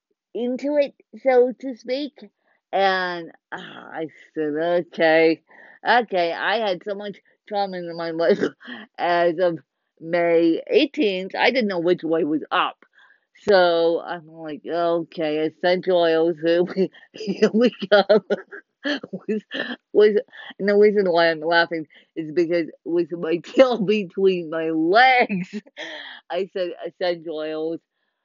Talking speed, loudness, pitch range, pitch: 125 wpm, -21 LUFS, 170-240 Hz, 185 Hz